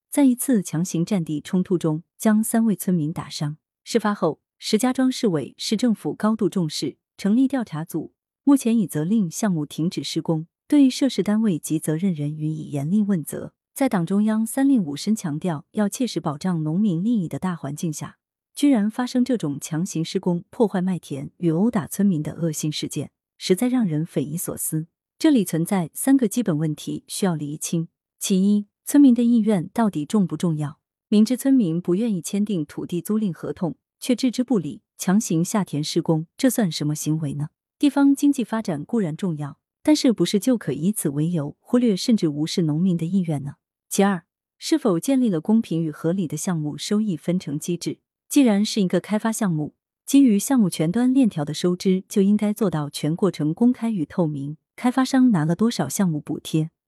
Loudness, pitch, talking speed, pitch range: -22 LUFS, 185 Hz, 290 characters per minute, 155-225 Hz